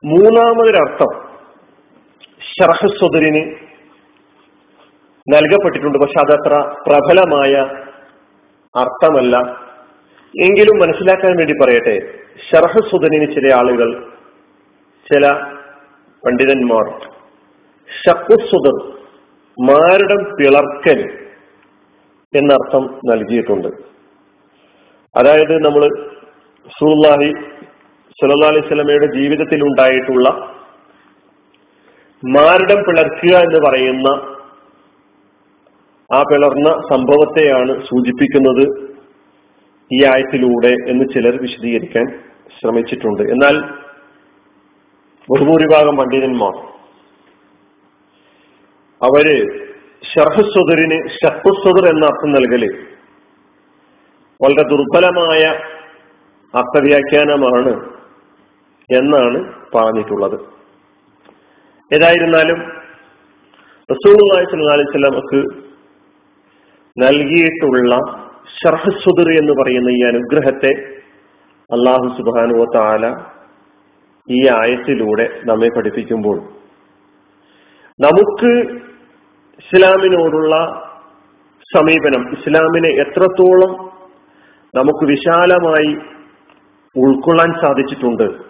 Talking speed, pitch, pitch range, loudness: 55 wpm, 145 Hz, 130-165 Hz, -12 LUFS